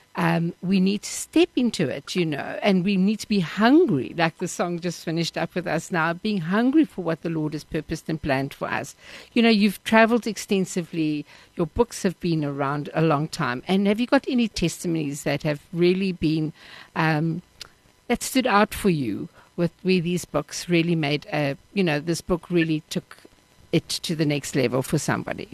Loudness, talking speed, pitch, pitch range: -24 LUFS, 200 wpm, 170 Hz, 160-195 Hz